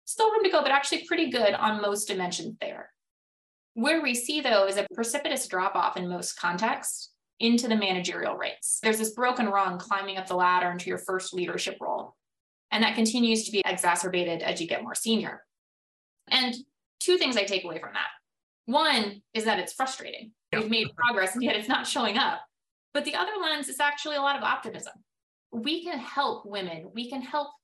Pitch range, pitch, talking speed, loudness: 195-285 Hz, 225 Hz, 200 wpm, -27 LUFS